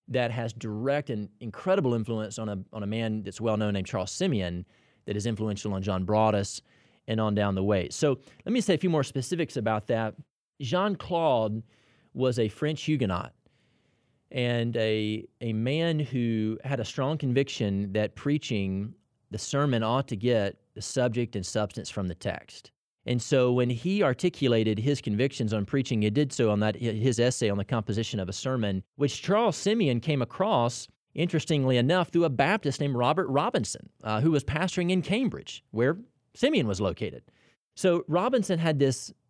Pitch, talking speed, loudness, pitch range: 120 Hz, 175 wpm, -28 LUFS, 110-145 Hz